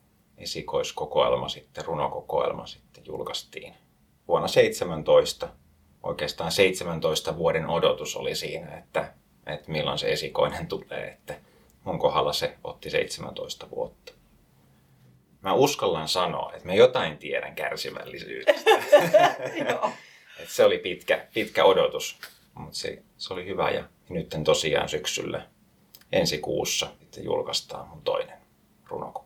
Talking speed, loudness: 110 wpm, -26 LUFS